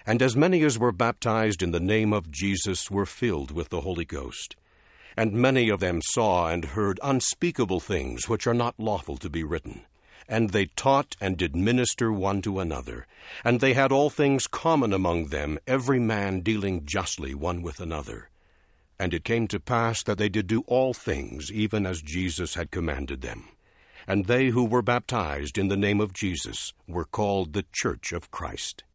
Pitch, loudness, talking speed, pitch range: 100 Hz, -26 LUFS, 185 wpm, 85-120 Hz